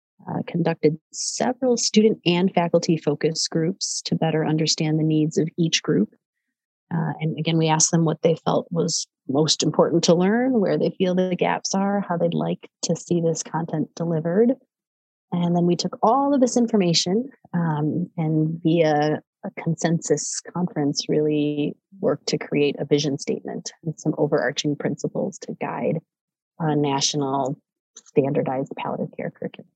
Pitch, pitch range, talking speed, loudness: 165 Hz, 155-180 Hz, 155 wpm, -22 LUFS